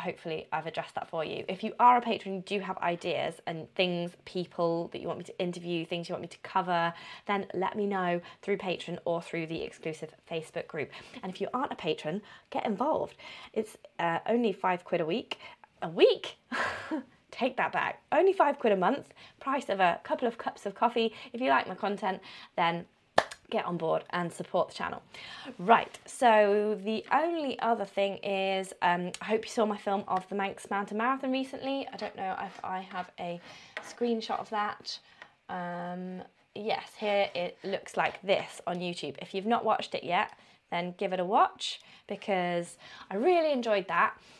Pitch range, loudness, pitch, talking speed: 175-230 Hz, -31 LUFS, 195 Hz, 195 wpm